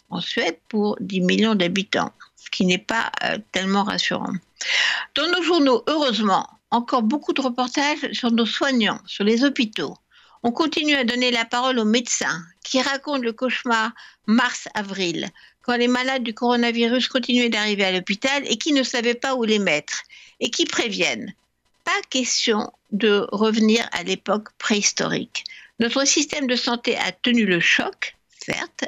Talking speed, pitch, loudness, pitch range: 160 wpm, 240 Hz, -21 LUFS, 215-270 Hz